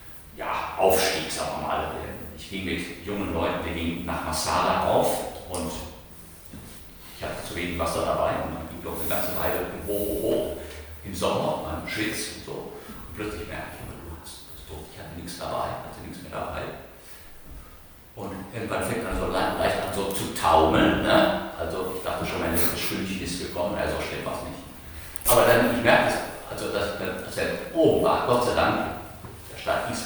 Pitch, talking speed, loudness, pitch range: 85 Hz, 190 wpm, -26 LUFS, 80-95 Hz